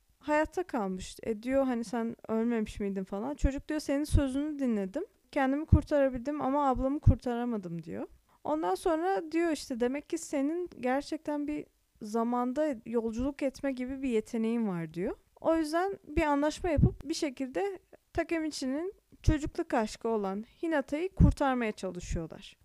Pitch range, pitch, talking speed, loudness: 230-310 Hz, 275 Hz, 135 wpm, -32 LUFS